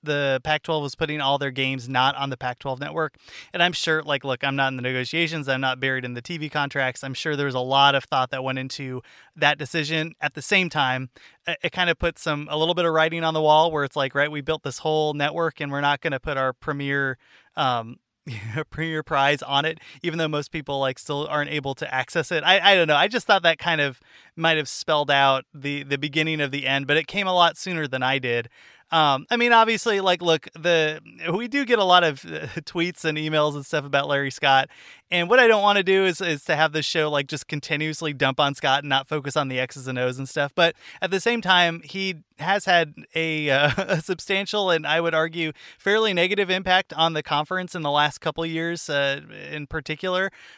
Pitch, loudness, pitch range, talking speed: 155 Hz, -22 LUFS, 140-170 Hz, 240 wpm